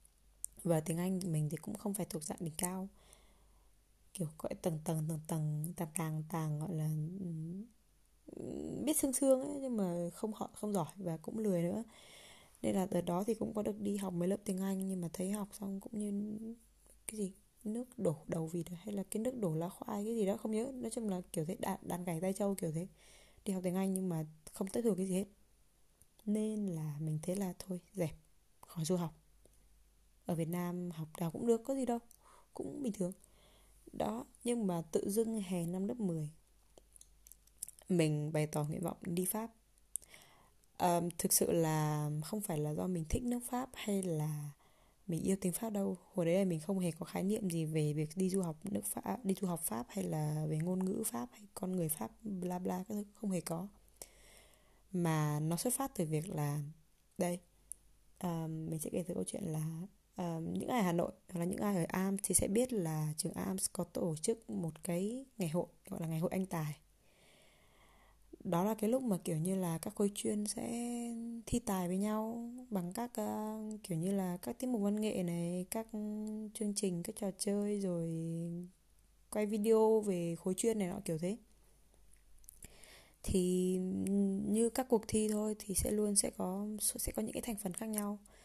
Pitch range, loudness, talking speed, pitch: 170-210 Hz, -38 LUFS, 205 wpm, 185 Hz